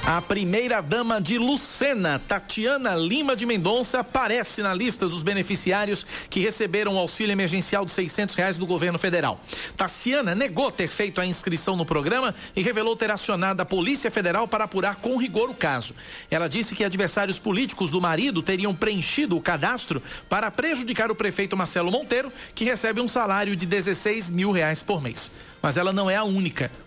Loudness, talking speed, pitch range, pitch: -24 LUFS, 180 wpm, 180-225 Hz, 200 Hz